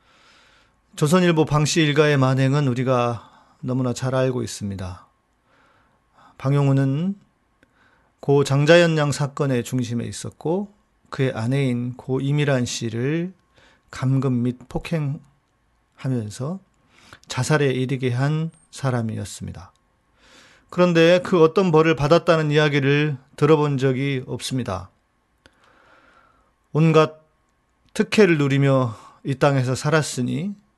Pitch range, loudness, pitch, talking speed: 125-155 Hz, -21 LUFS, 140 Hz, 230 characters per minute